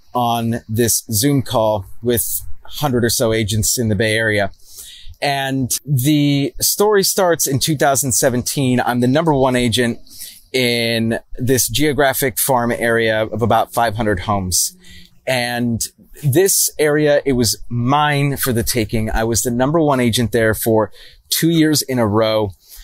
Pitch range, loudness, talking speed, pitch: 110-135 Hz, -16 LUFS, 145 wpm, 120 Hz